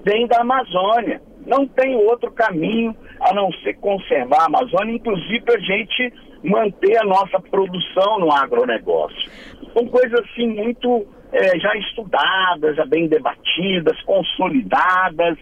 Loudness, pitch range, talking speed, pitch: -18 LUFS, 190-255 Hz, 130 wpm, 225 Hz